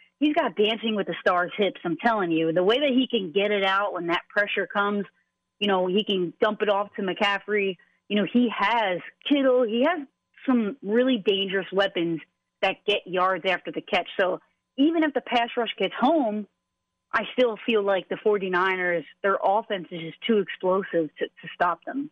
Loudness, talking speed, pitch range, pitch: -25 LUFS, 195 wpm, 190-235 Hz, 205 Hz